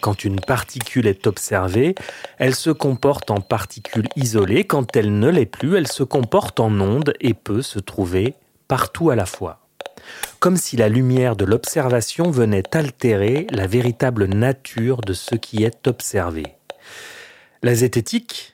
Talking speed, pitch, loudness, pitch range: 150 wpm, 120 Hz, -19 LUFS, 105-135 Hz